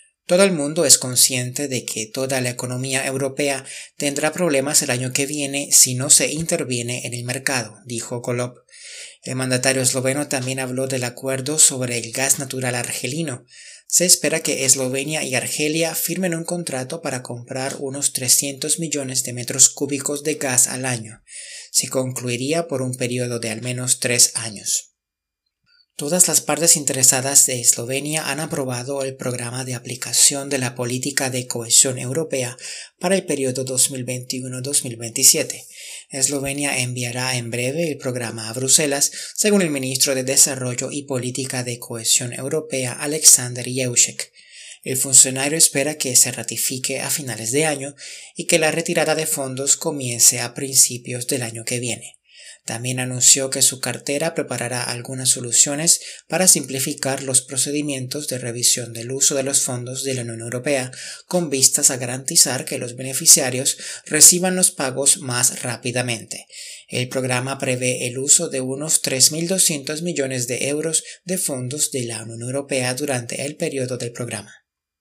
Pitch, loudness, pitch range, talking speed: 130 Hz, -18 LUFS, 125-145 Hz, 155 wpm